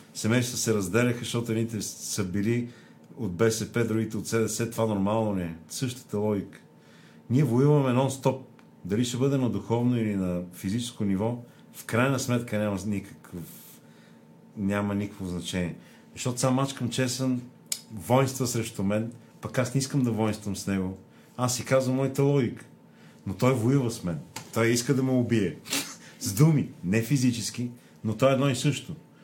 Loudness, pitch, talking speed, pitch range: -27 LUFS, 115 Hz, 160 wpm, 105-130 Hz